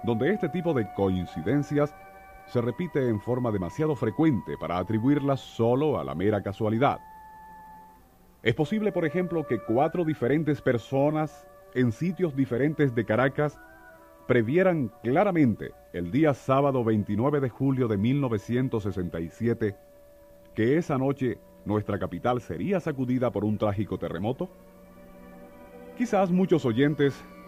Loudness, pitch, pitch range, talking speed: -27 LUFS, 130 Hz, 105-155 Hz, 120 wpm